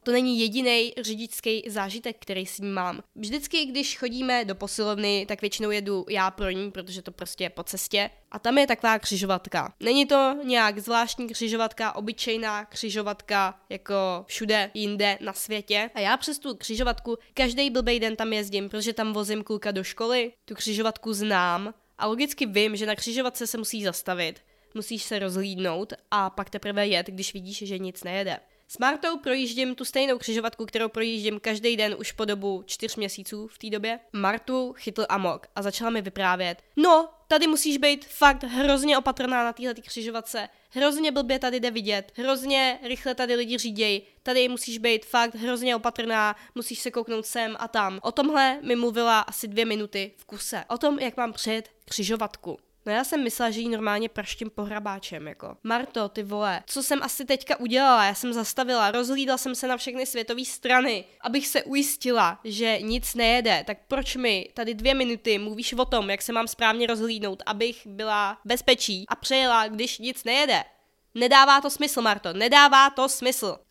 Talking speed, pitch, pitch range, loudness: 175 wpm, 225 Hz, 210-250 Hz, -25 LUFS